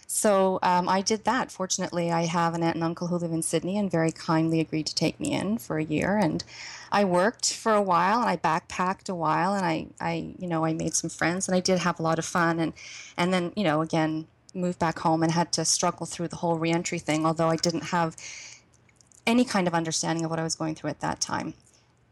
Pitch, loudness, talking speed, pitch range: 170 Hz, -26 LUFS, 245 wpm, 160-185 Hz